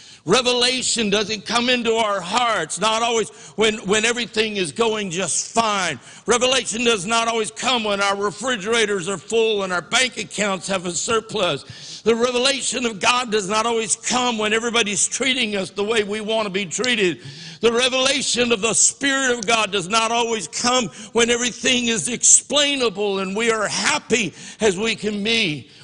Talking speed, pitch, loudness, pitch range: 170 wpm, 220 Hz, -19 LUFS, 200-235 Hz